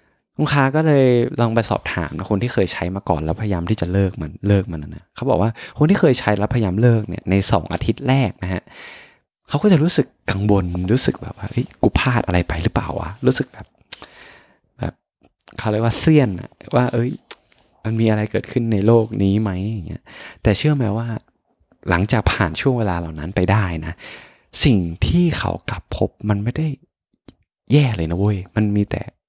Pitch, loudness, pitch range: 105 Hz, -19 LUFS, 95-125 Hz